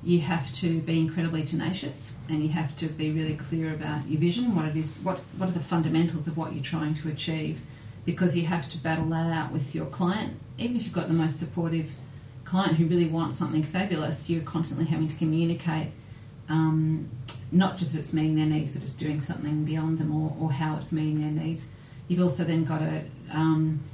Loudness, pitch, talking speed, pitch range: -28 LUFS, 155 Hz, 215 wpm, 150-165 Hz